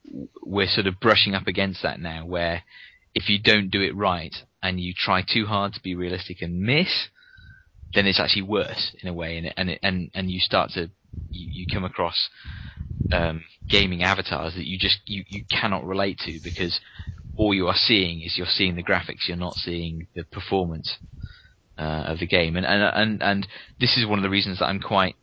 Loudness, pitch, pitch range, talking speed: -23 LUFS, 95 Hz, 85-100 Hz, 205 wpm